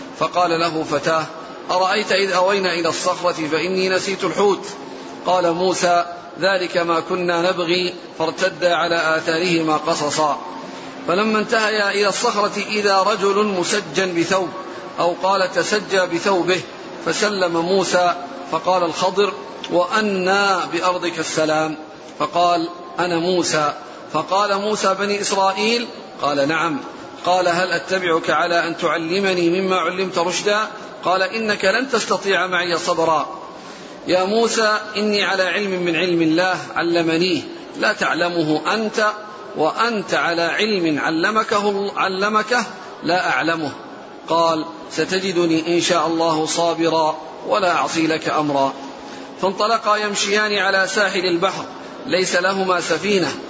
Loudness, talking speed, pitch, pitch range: -19 LUFS, 115 wpm, 180 Hz, 170-200 Hz